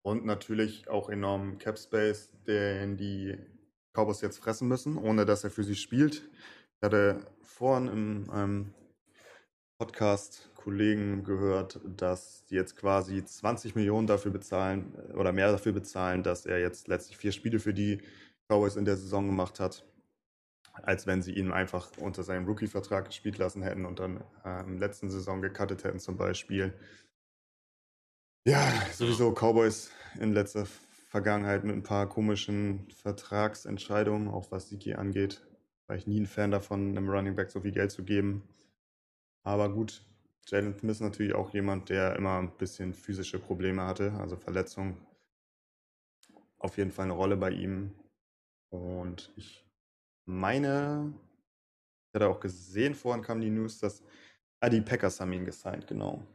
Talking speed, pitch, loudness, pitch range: 150 wpm, 100 Hz, -32 LUFS, 95-105 Hz